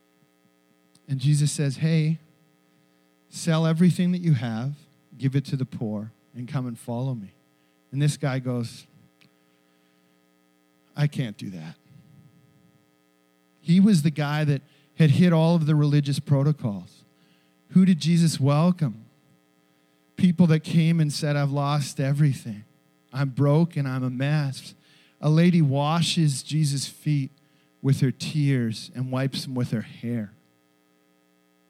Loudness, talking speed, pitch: -24 LUFS, 135 wpm, 135 Hz